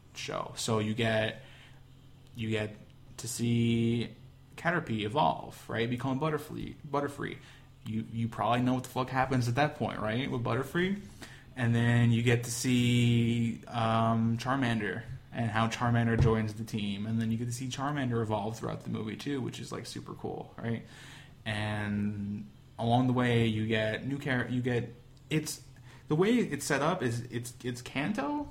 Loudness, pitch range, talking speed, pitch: -31 LUFS, 115-130 Hz, 170 wpm, 120 Hz